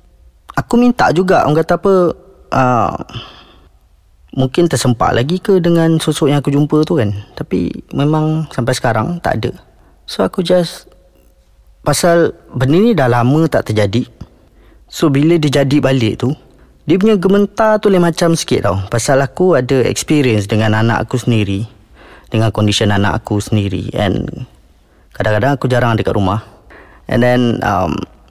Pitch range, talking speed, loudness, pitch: 105-160 Hz, 150 wpm, -14 LUFS, 130 Hz